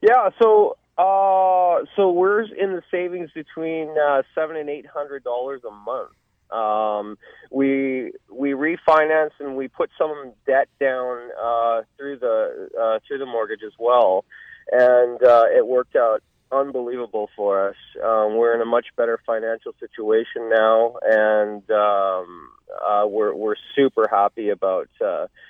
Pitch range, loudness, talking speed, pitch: 115-175 Hz, -20 LUFS, 150 wpm, 135 Hz